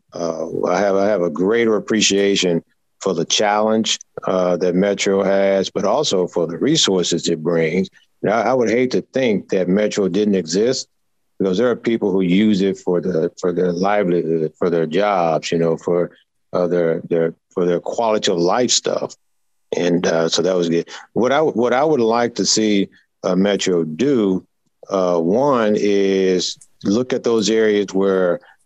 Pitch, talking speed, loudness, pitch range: 95 Hz, 180 wpm, -18 LUFS, 90-105 Hz